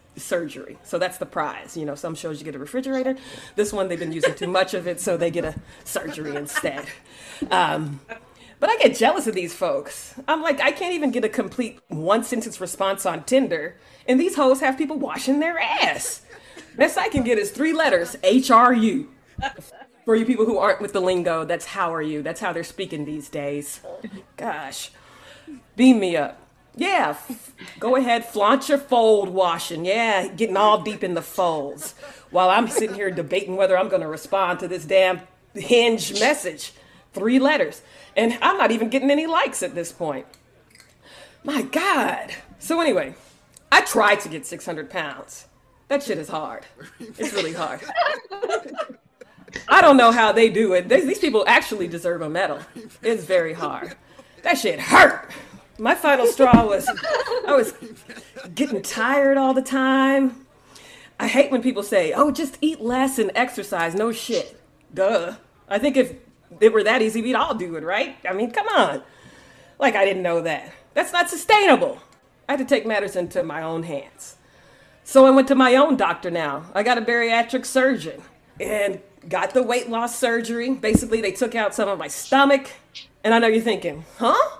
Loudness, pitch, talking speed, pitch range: -20 LUFS, 225 Hz, 185 wpm, 185-265 Hz